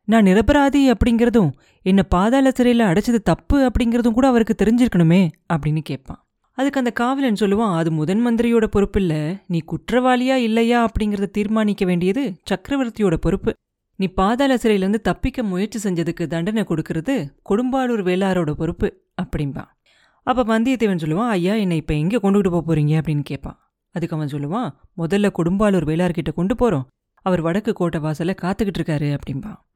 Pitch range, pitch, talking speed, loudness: 165-230 Hz, 195 Hz, 140 wpm, -19 LUFS